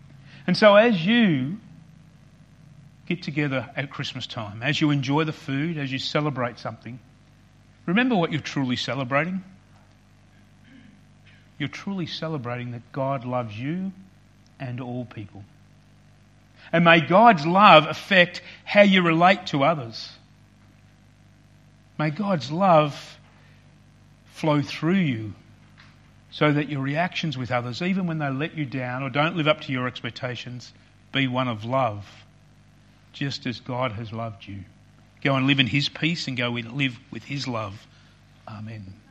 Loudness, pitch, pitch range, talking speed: -23 LUFS, 135 Hz, 120-155 Hz, 140 wpm